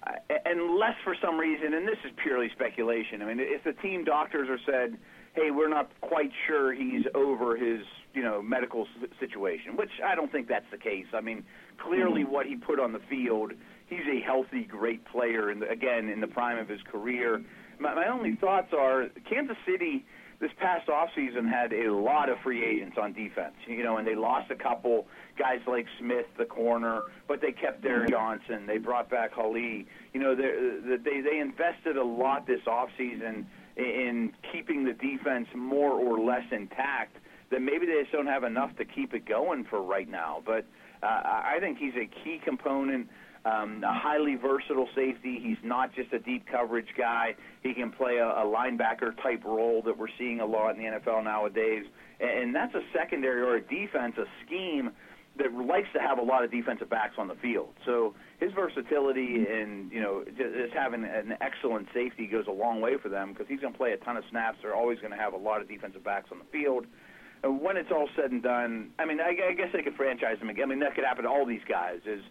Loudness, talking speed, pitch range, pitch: -30 LUFS, 210 wpm, 115-150 Hz, 125 Hz